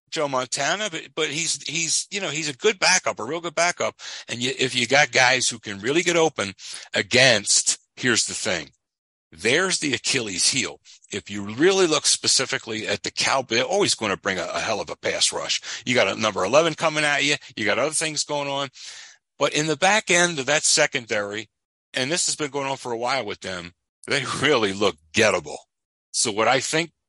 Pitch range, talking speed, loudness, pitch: 130-165 Hz, 215 wpm, -21 LUFS, 150 Hz